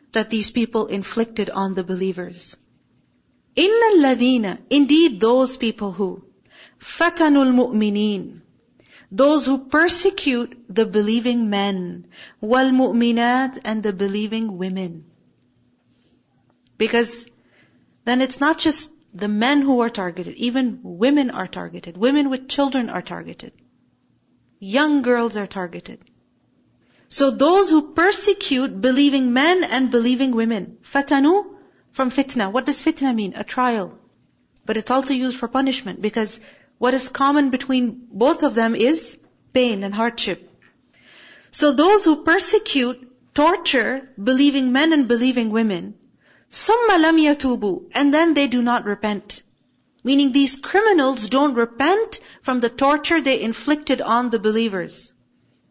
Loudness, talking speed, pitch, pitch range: -19 LUFS, 125 wpm, 255 Hz, 225-285 Hz